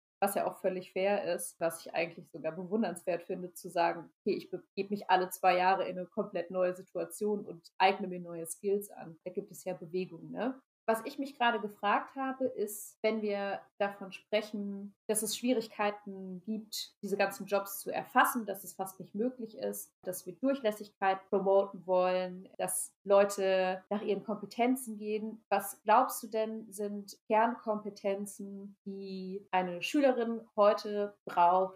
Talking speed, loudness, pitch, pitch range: 160 wpm, -33 LUFS, 200 Hz, 185-215 Hz